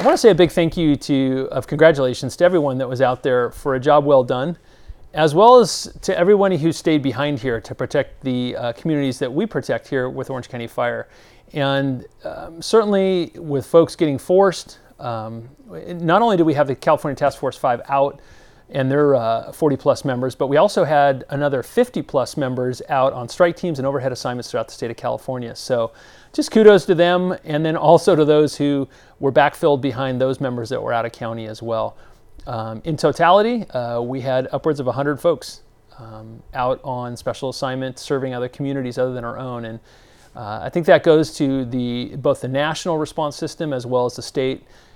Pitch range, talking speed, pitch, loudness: 125-160 Hz, 205 wpm, 135 Hz, -19 LUFS